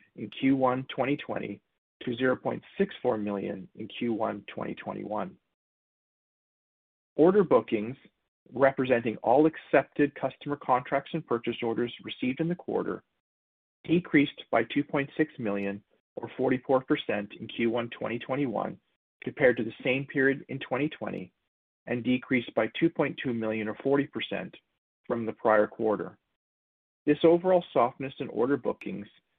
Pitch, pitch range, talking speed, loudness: 125 Hz, 110-145 Hz, 115 wpm, -29 LUFS